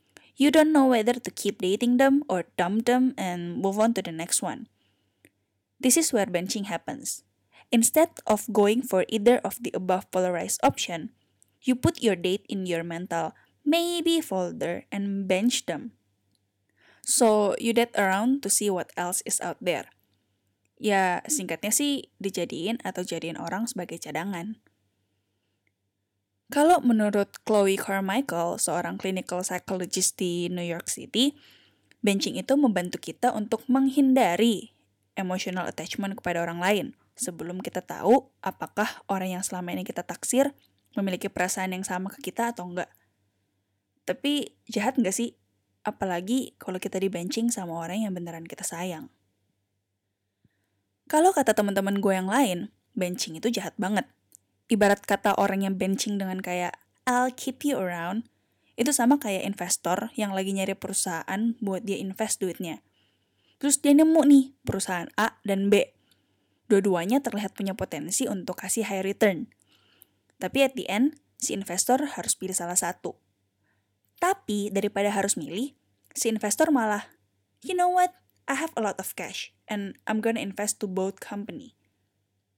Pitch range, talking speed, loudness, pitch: 175-230 Hz, 145 wpm, -26 LUFS, 195 Hz